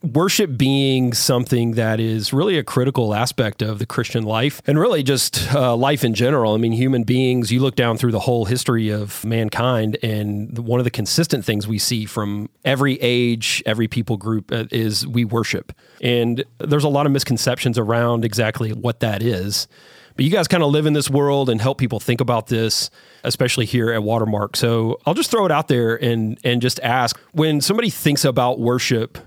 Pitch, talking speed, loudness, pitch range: 120 Hz, 200 wpm, -19 LUFS, 115-135 Hz